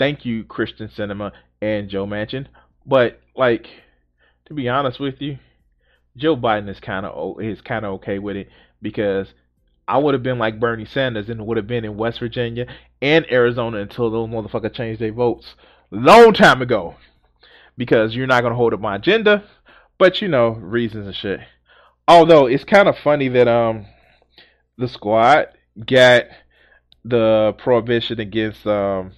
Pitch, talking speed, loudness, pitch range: 115 Hz, 155 wpm, -17 LUFS, 105-125 Hz